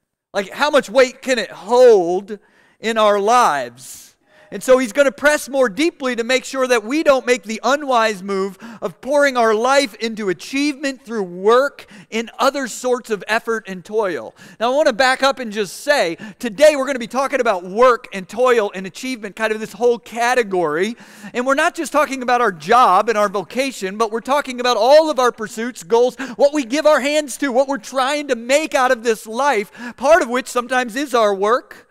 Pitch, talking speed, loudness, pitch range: 245 Hz, 210 wpm, -17 LUFS, 215-275 Hz